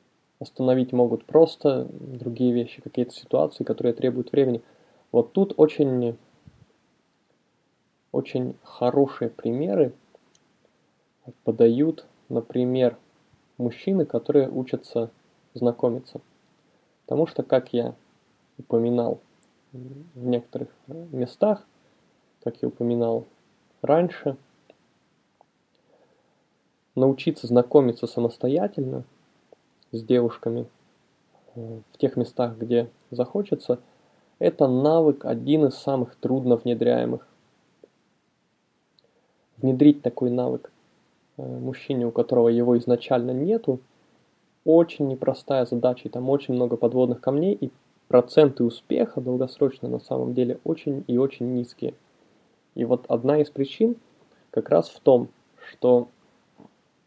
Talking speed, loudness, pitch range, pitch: 95 wpm, -24 LUFS, 120-140 Hz, 125 Hz